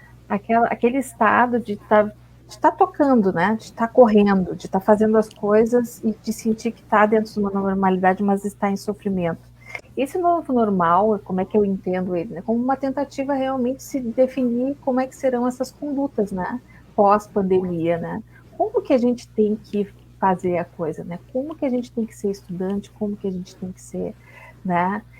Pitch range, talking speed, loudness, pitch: 190-245 Hz, 200 wpm, -21 LUFS, 215 Hz